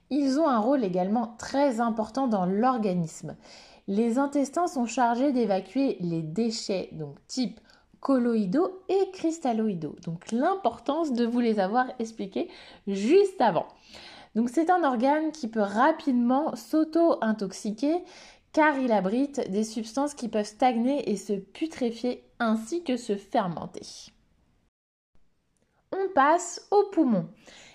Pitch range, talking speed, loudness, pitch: 215-285 Hz, 125 wpm, -27 LUFS, 245 Hz